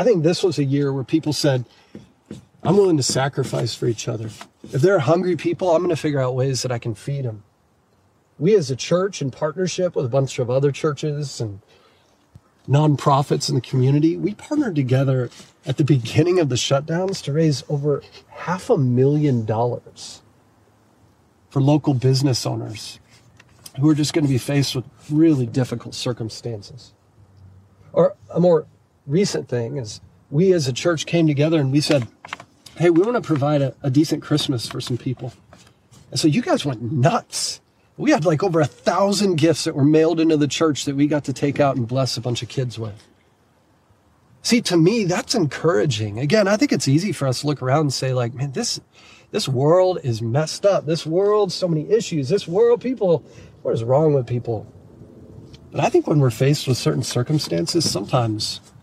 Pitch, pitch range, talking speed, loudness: 140 Hz, 120-160 Hz, 190 wpm, -20 LUFS